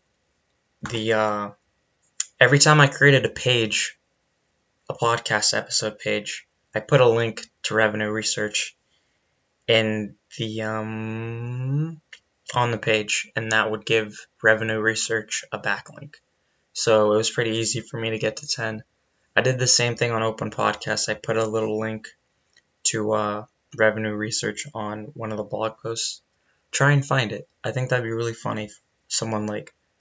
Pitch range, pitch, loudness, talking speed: 110-115 Hz, 110 Hz, -23 LUFS, 160 wpm